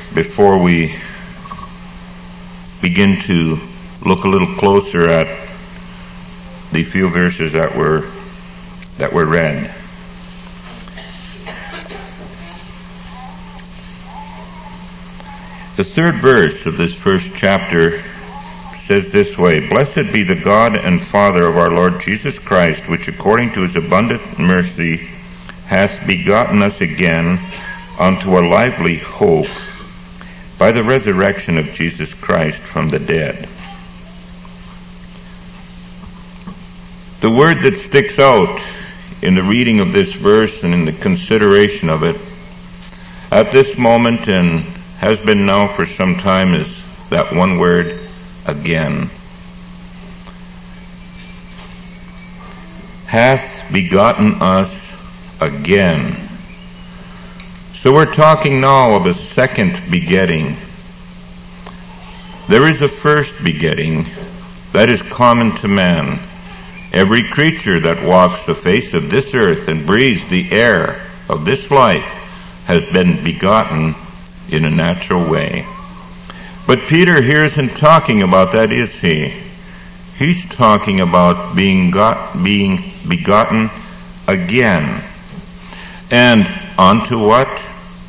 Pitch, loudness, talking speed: 115 Hz, -13 LUFS, 110 wpm